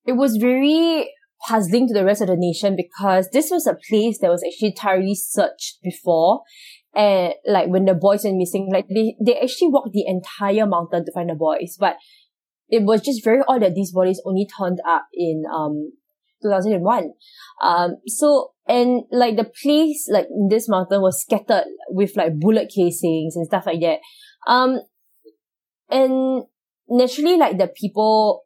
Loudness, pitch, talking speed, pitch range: -19 LUFS, 210 Hz, 175 wpm, 185-255 Hz